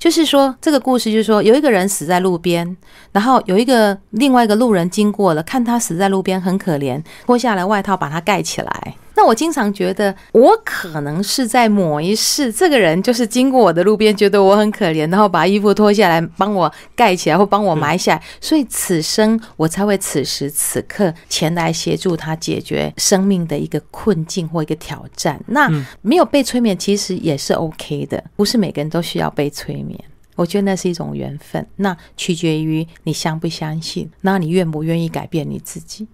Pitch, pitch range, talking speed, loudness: 190 Hz, 165-215 Hz, 305 characters per minute, -16 LUFS